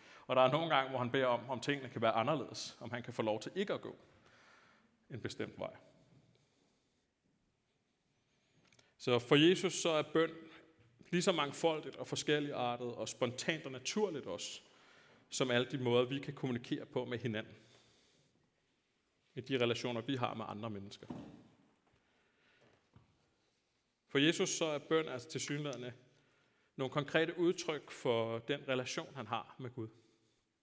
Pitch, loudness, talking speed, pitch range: 130 Hz, -37 LUFS, 155 wpm, 120-150 Hz